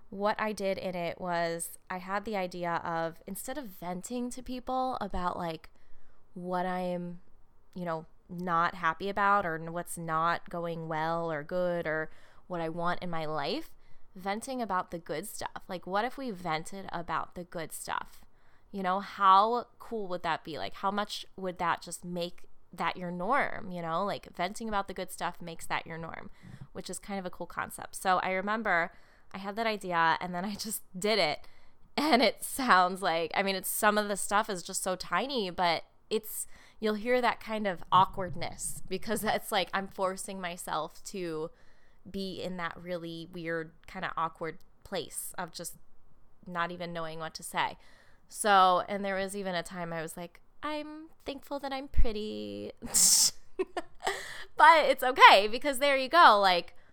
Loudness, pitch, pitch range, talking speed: -30 LUFS, 185 Hz, 170-205 Hz, 180 wpm